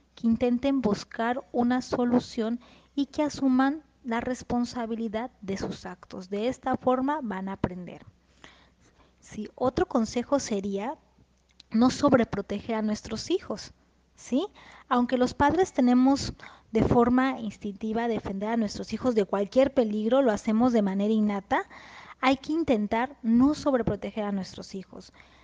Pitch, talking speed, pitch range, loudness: 240 Hz, 130 wpm, 210-260 Hz, -27 LUFS